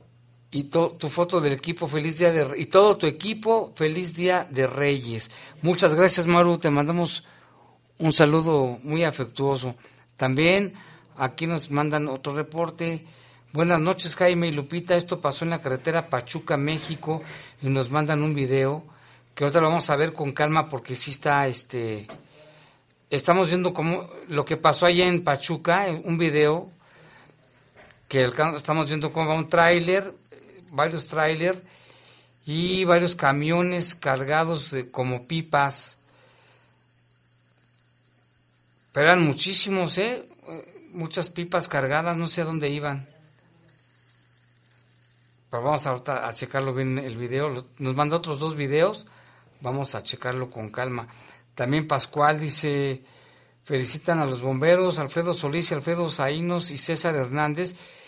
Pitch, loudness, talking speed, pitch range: 150 Hz, -23 LUFS, 135 wpm, 130-170 Hz